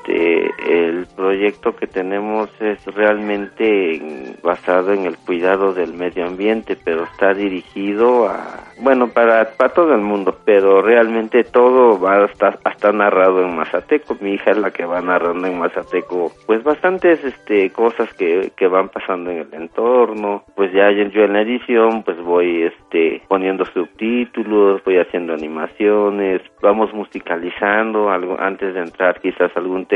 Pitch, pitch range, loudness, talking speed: 100 Hz, 90-115 Hz, -16 LUFS, 155 wpm